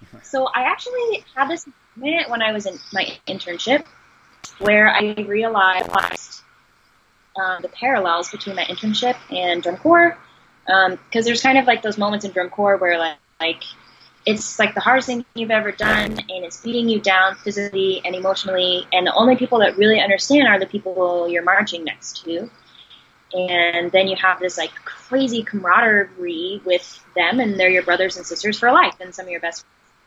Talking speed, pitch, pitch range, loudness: 185 wpm, 200 Hz, 180-230 Hz, -18 LUFS